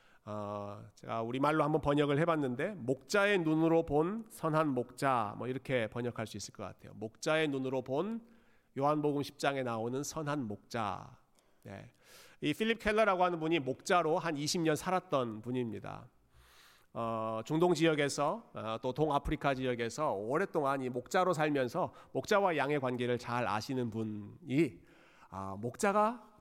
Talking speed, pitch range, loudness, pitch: 300 characters per minute, 120-160 Hz, -34 LUFS, 140 Hz